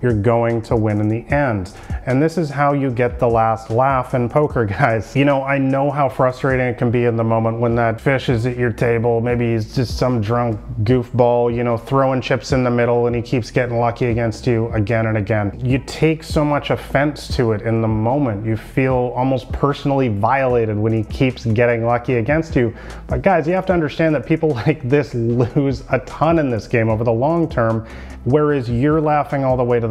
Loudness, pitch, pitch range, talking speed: -18 LUFS, 125 Hz, 115-140 Hz, 225 wpm